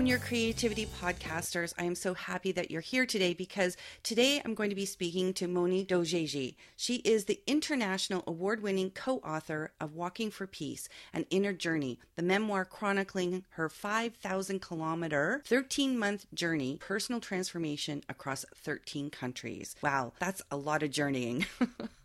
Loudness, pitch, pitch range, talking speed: -34 LUFS, 185 Hz, 160-210 Hz, 145 wpm